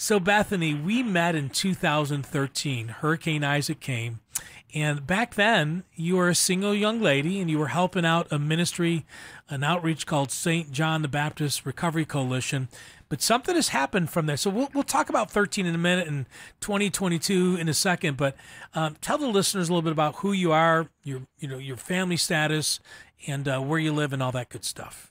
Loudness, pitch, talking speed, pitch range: -25 LUFS, 160 Hz, 200 wpm, 145-185 Hz